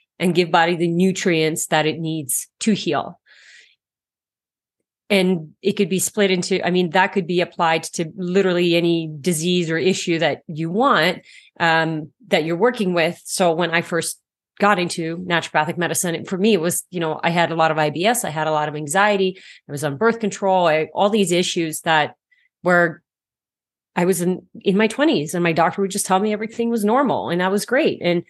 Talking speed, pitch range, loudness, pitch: 200 wpm, 165-195 Hz, -19 LUFS, 175 Hz